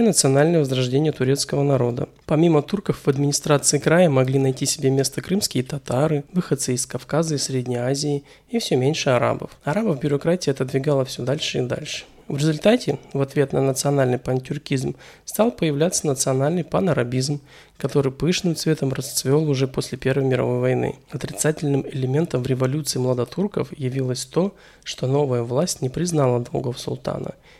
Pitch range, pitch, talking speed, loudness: 130-155 Hz, 140 Hz, 145 wpm, -22 LUFS